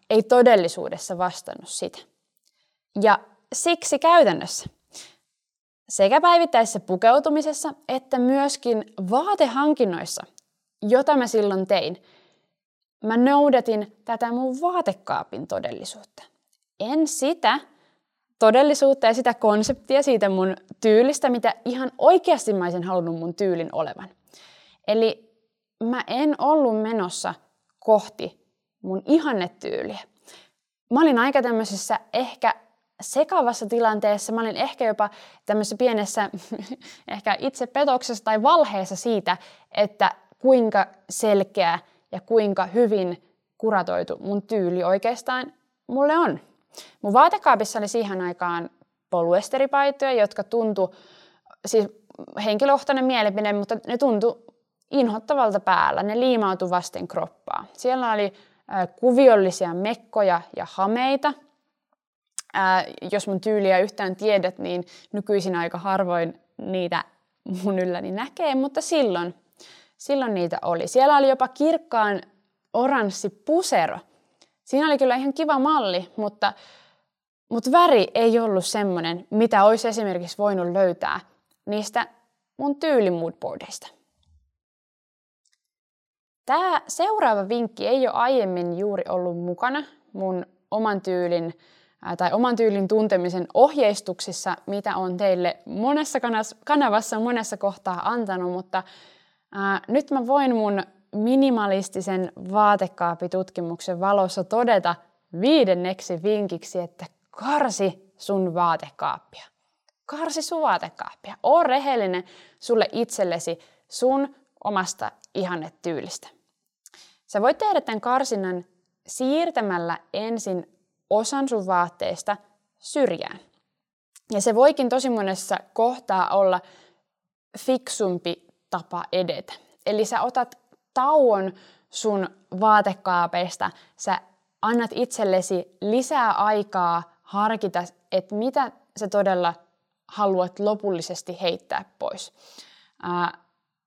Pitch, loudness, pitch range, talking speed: 210 Hz, -23 LUFS, 185-255 Hz, 100 wpm